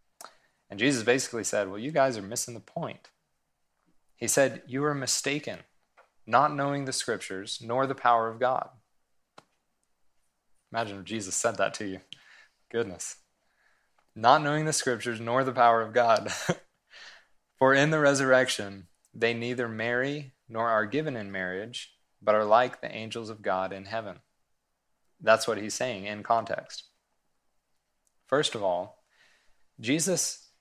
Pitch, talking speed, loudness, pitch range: 115 Hz, 145 wpm, -28 LUFS, 105-135 Hz